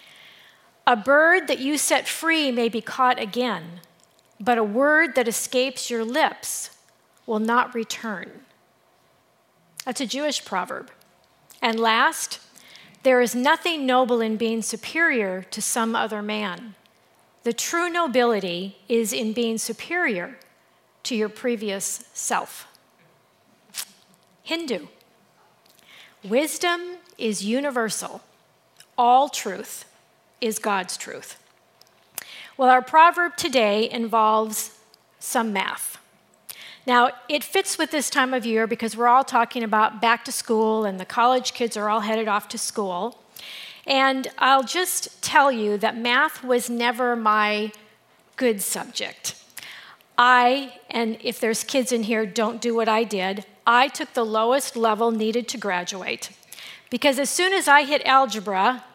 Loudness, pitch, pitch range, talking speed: -22 LUFS, 240 Hz, 220-265 Hz, 130 wpm